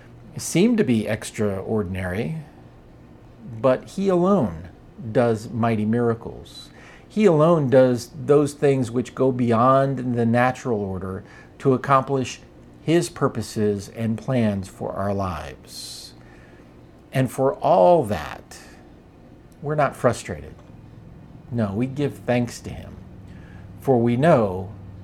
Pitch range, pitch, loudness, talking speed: 95-130 Hz, 115 Hz, -21 LUFS, 110 wpm